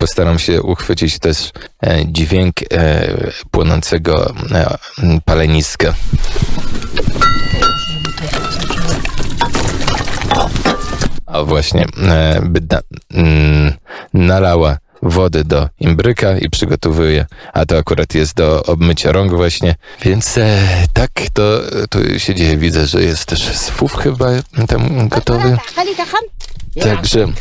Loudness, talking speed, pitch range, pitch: -14 LUFS, 100 wpm, 80-110 Hz, 85 Hz